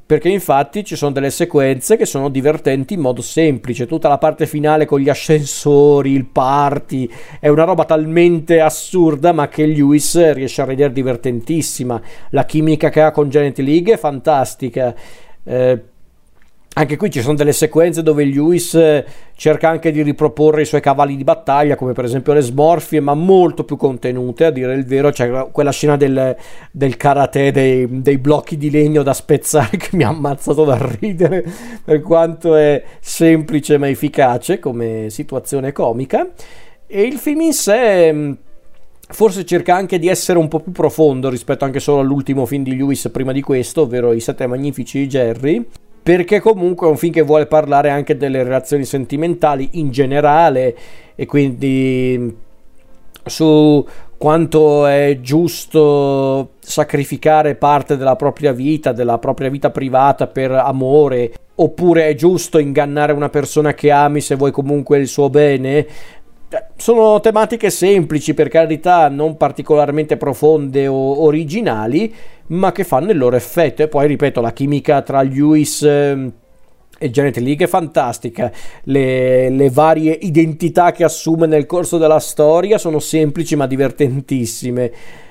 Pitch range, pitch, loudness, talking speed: 135-160 Hz, 150 Hz, -14 LUFS, 155 wpm